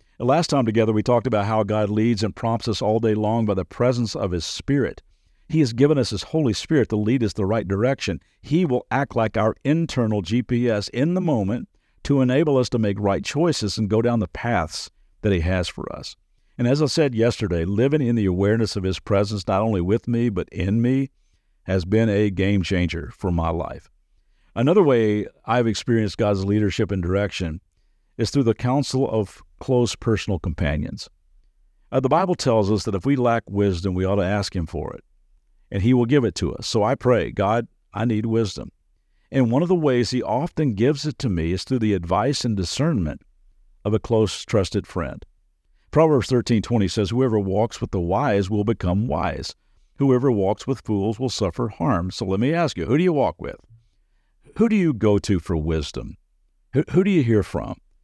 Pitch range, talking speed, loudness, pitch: 95-125 Hz, 205 wpm, -22 LUFS, 110 Hz